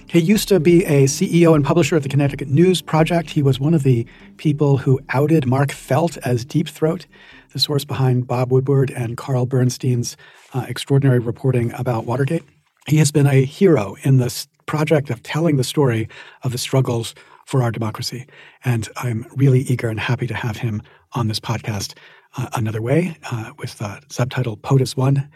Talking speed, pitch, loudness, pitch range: 180 wpm, 135 Hz, -19 LUFS, 120-150 Hz